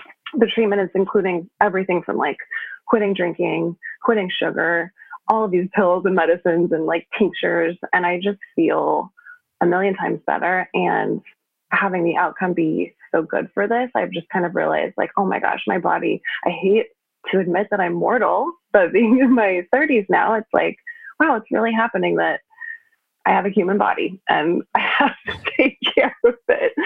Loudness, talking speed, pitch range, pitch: -19 LUFS, 180 wpm, 180-265 Hz, 205 Hz